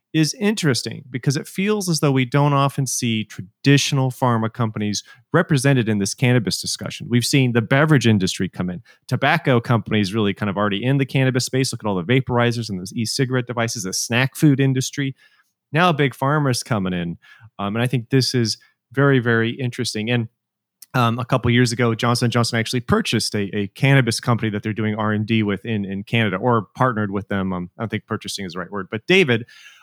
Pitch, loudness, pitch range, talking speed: 120 Hz, -20 LUFS, 110-135 Hz, 205 wpm